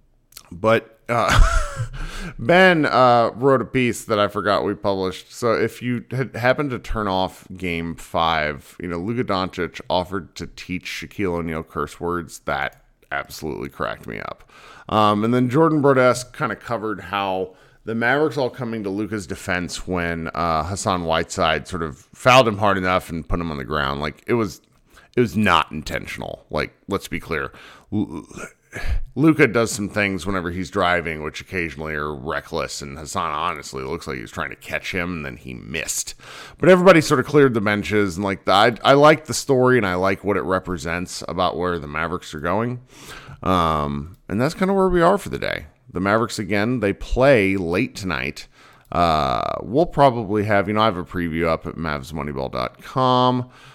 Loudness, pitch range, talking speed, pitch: -21 LUFS, 85-125 Hz, 185 wpm, 100 Hz